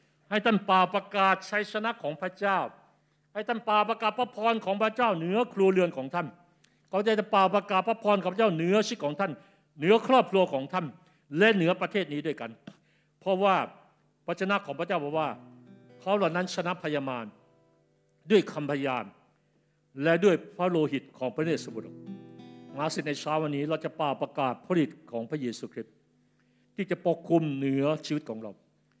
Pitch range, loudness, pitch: 145-195 Hz, -28 LUFS, 170 Hz